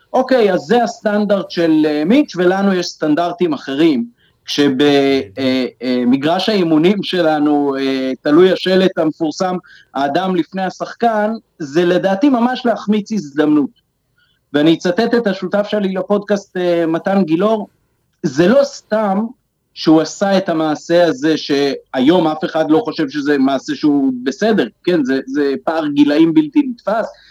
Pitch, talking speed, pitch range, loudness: 175 Hz, 125 wpm, 150-210 Hz, -15 LUFS